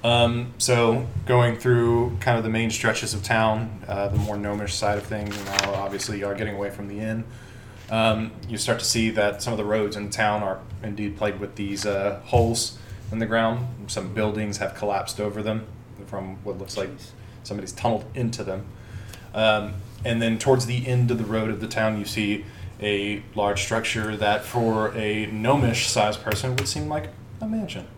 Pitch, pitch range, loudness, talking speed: 110 Hz, 105-115 Hz, -25 LUFS, 195 wpm